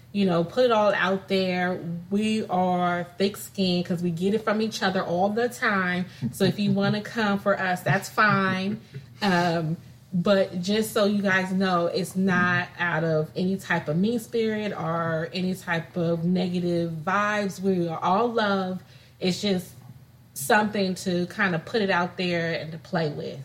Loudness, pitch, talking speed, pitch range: -25 LUFS, 185 Hz, 180 wpm, 170-200 Hz